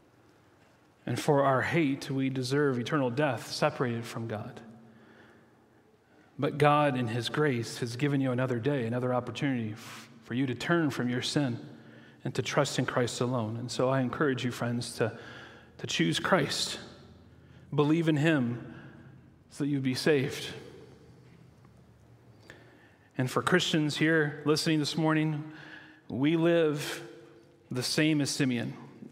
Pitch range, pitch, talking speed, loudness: 120-150 Hz, 135 Hz, 140 wpm, -29 LUFS